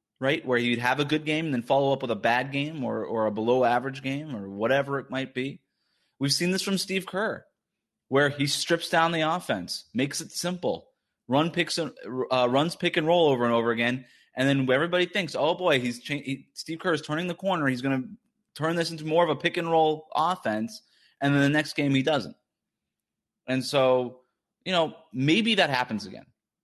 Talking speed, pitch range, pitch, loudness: 215 wpm, 130-165 Hz, 140 Hz, -26 LUFS